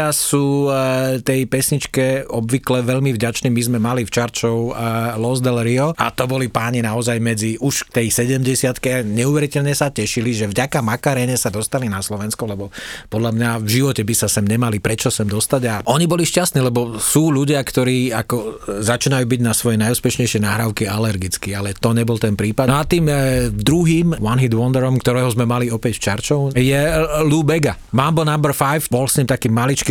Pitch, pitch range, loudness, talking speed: 125 Hz, 115-135 Hz, -17 LUFS, 185 wpm